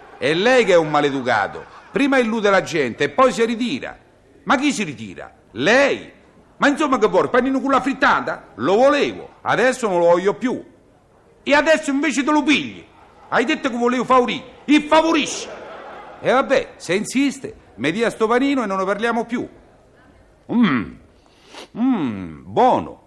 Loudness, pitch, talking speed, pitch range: -18 LUFS, 255 Hz, 165 wpm, 215-275 Hz